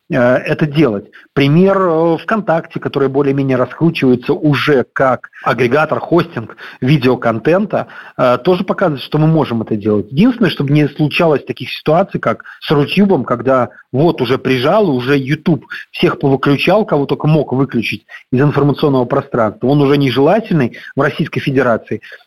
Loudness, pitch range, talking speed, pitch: -14 LUFS, 130-160 Hz, 130 wpm, 145 Hz